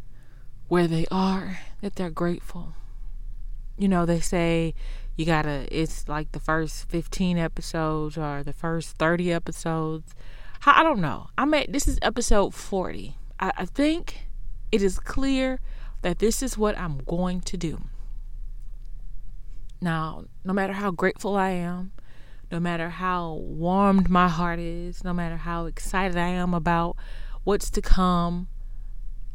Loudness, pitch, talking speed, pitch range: -26 LUFS, 170 Hz, 145 wpm, 155-185 Hz